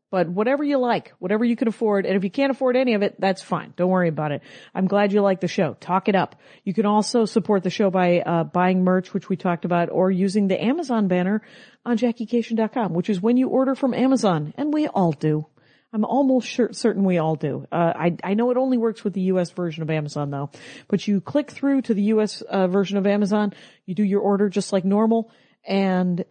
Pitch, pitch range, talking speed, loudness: 200 Hz, 180-230 Hz, 235 wpm, -22 LUFS